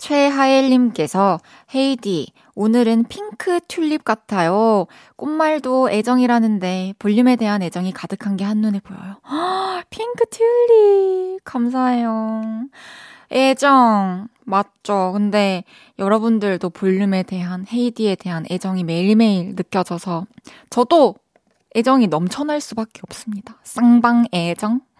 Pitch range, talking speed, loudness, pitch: 195-260 Hz, 255 characters per minute, -18 LUFS, 220 Hz